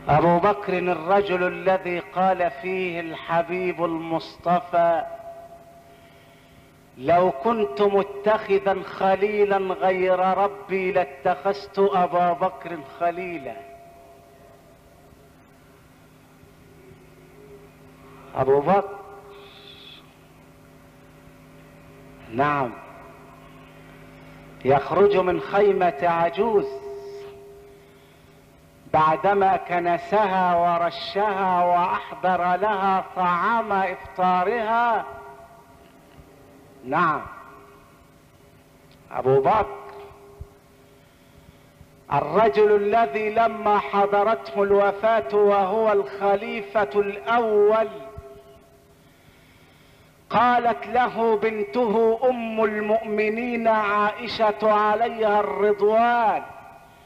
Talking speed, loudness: 55 wpm, -22 LUFS